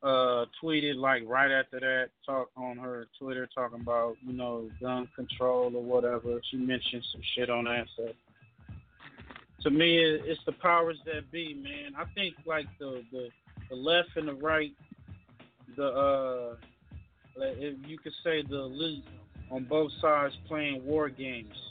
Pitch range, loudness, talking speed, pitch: 120-155 Hz, -31 LUFS, 160 wpm, 130 Hz